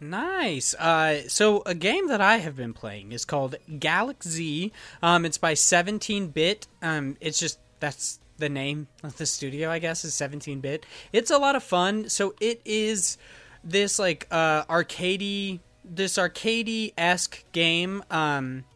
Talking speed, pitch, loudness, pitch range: 155 wpm, 165 Hz, -25 LUFS, 150-200 Hz